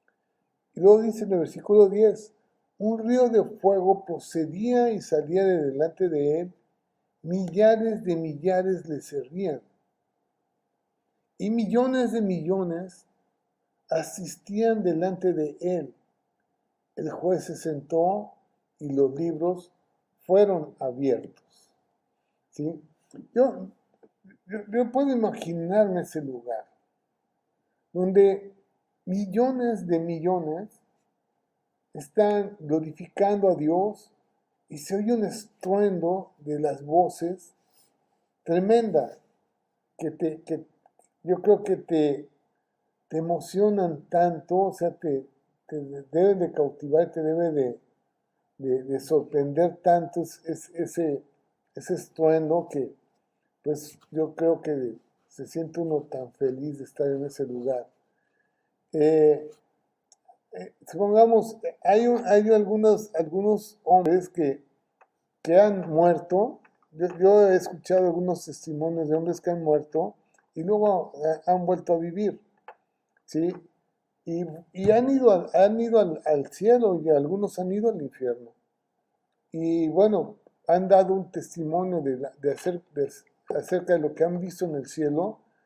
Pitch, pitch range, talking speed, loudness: 175 Hz, 155-200 Hz, 120 wpm, -25 LUFS